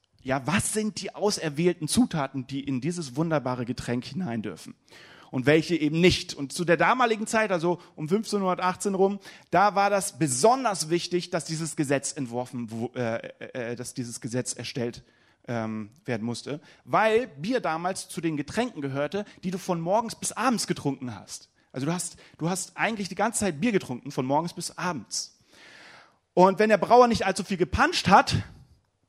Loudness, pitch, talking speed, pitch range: -26 LUFS, 165 Hz, 165 wpm, 135-195 Hz